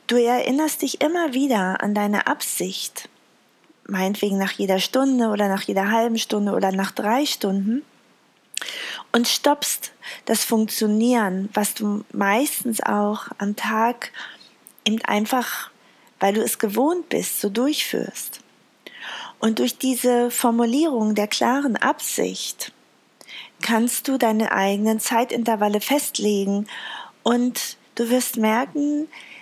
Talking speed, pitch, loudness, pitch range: 115 wpm, 230 Hz, -22 LUFS, 210-260 Hz